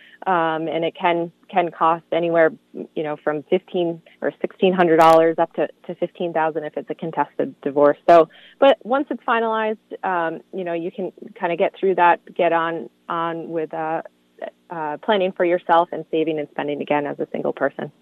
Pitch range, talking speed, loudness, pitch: 160-180 Hz, 195 wpm, -20 LUFS, 165 Hz